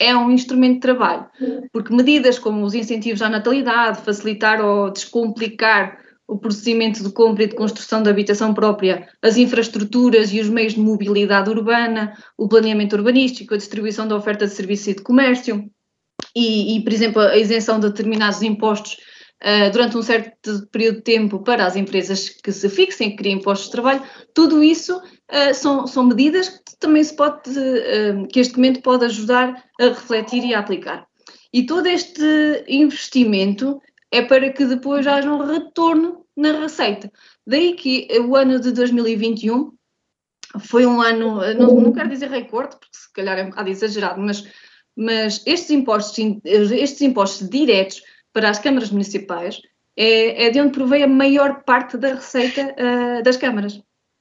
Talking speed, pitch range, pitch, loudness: 165 wpm, 210-255 Hz, 230 Hz, -17 LUFS